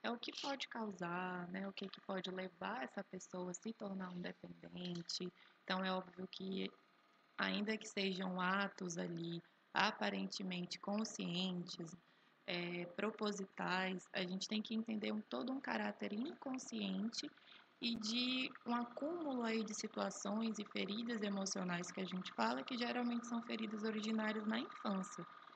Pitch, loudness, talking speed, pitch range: 200 Hz, -43 LUFS, 145 wpm, 185-225 Hz